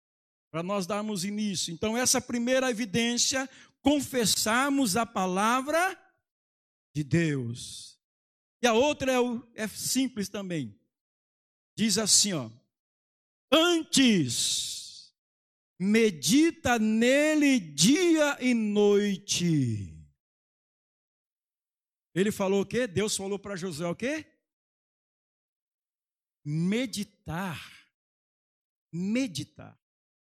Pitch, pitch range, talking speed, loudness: 205 Hz, 160-250 Hz, 85 wpm, -27 LUFS